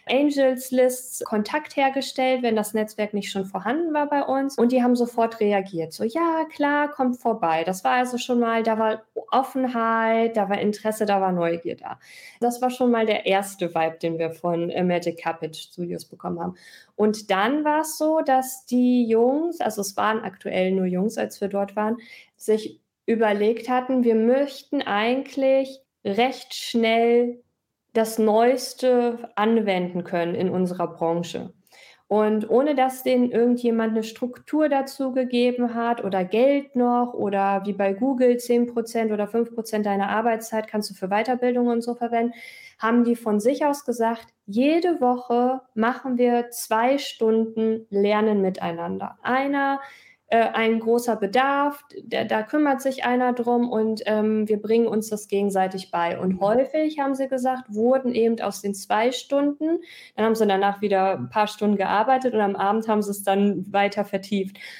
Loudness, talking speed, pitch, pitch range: -23 LUFS, 165 wpm, 230 Hz, 205-255 Hz